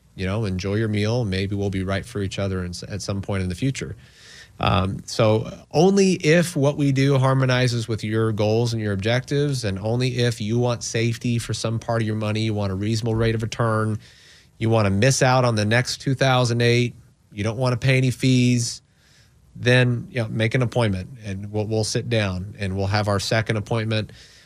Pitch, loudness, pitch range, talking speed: 115 Hz, -22 LUFS, 105-125 Hz, 210 wpm